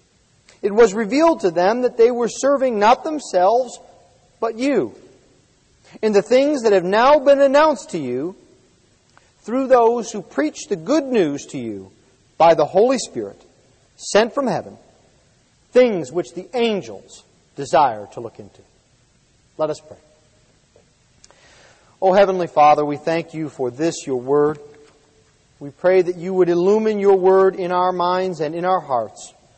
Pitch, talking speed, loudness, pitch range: 185 Hz, 155 wpm, -18 LUFS, 150-235 Hz